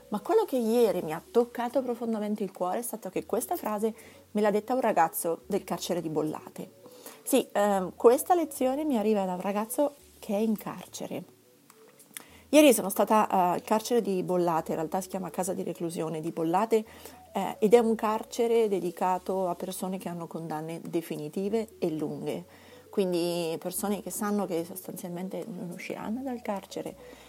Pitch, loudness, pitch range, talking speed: 200 Hz, -29 LUFS, 175-225 Hz, 170 wpm